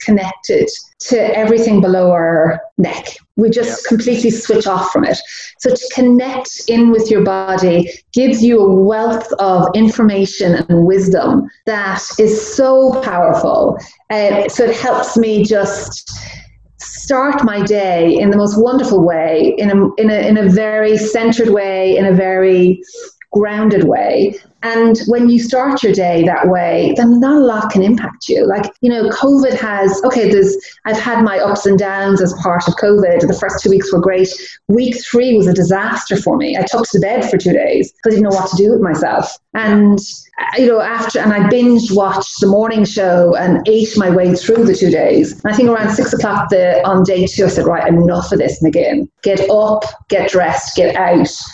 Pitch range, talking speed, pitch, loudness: 190-230 Hz, 190 wpm, 210 Hz, -12 LUFS